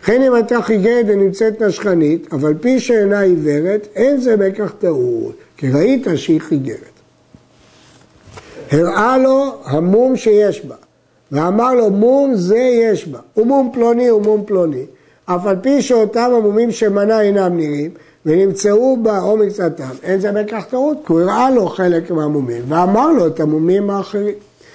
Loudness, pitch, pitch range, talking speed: -14 LUFS, 210 Hz, 175-240 Hz, 150 wpm